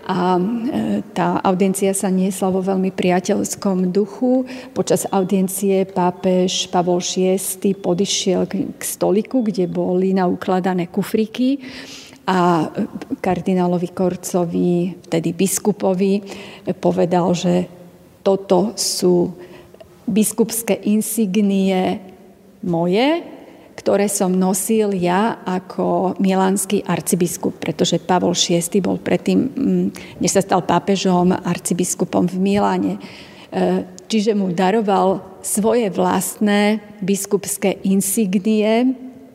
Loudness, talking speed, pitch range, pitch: -18 LUFS, 90 wpm, 180-205 Hz, 190 Hz